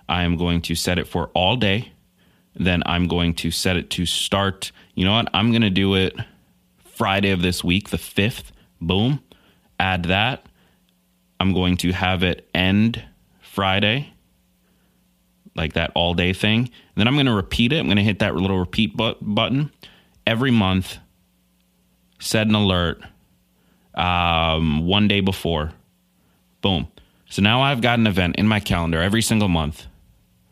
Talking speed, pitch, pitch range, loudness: 165 wpm, 90 Hz, 85-105 Hz, -20 LUFS